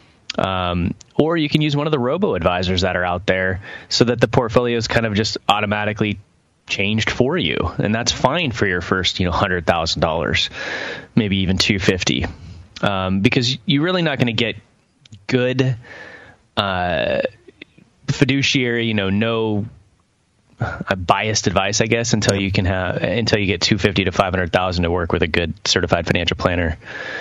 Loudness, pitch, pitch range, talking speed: -19 LUFS, 105 Hz, 95-120 Hz, 180 wpm